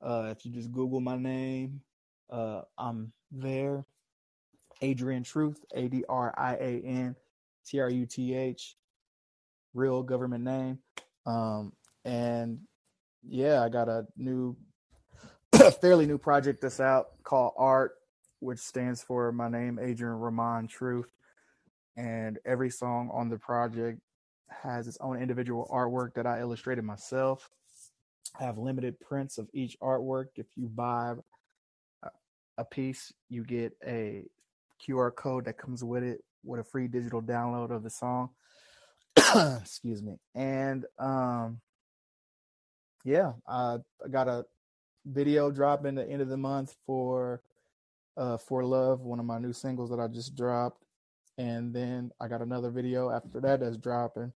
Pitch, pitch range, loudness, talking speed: 125 Hz, 120-130 Hz, -31 LUFS, 145 wpm